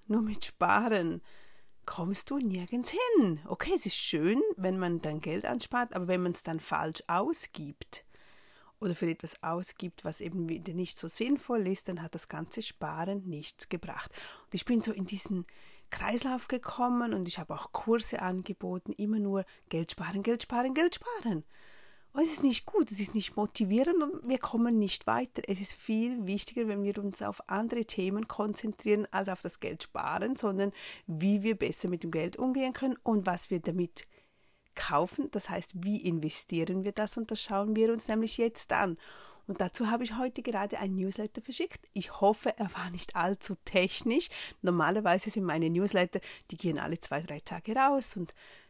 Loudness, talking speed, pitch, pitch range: -32 LUFS, 185 wpm, 200 Hz, 180-230 Hz